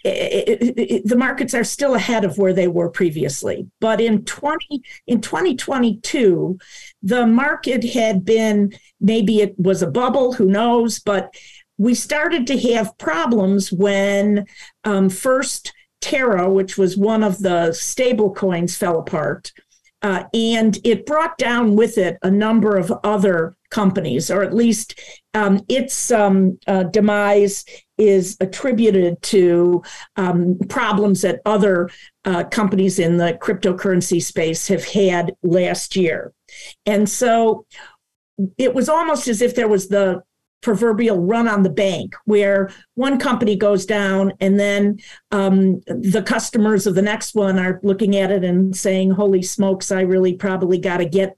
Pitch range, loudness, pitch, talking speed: 190-230 Hz, -18 LUFS, 205 Hz, 155 wpm